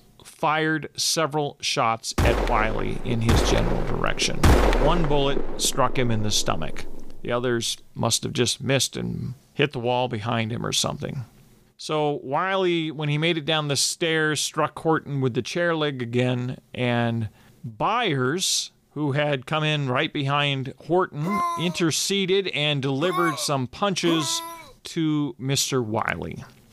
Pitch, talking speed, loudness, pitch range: 140 Hz, 140 wpm, -24 LUFS, 120-155 Hz